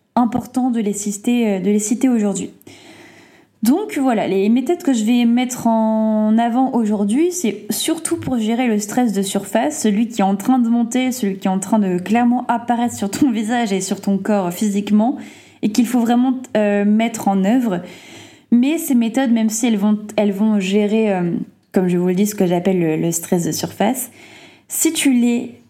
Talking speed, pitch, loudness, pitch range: 200 wpm, 225 Hz, -17 LUFS, 205-250 Hz